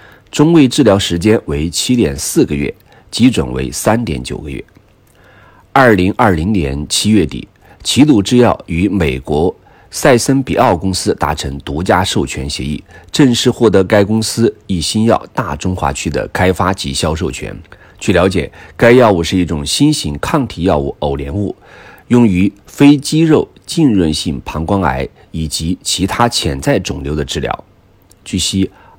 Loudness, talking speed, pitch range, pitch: -13 LUFS, 230 characters per minute, 80-110 Hz, 95 Hz